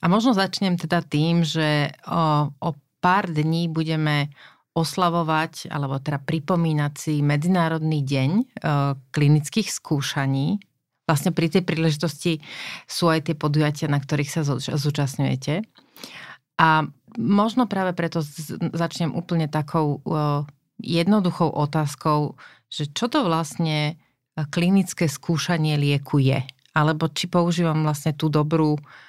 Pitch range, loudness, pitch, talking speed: 150-170 Hz, -23 LUFS, 160 Hz, 120 wpm